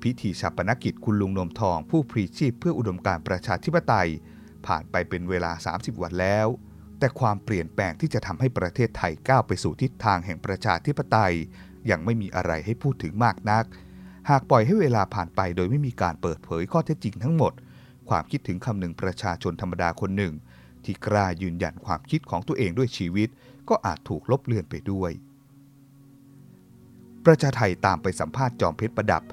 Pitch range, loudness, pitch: 90-130 Hz, -26 LUFS, 105 Hz